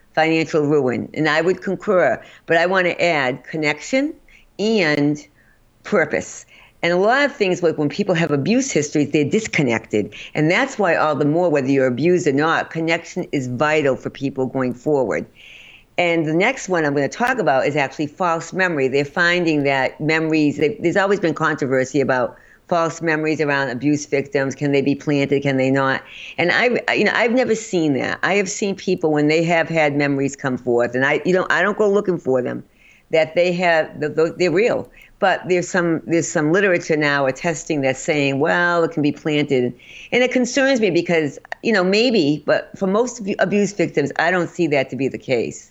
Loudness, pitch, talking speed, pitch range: -19 LUFS, 160 Hz, 195 wpm, 145-180 Hz